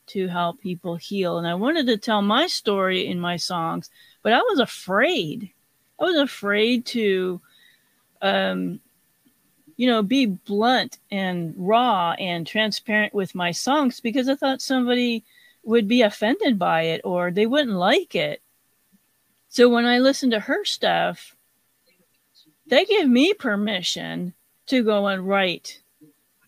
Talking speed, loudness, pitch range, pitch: 145 wpm, -22 LUFS, 180-250 Hz, 215 Hz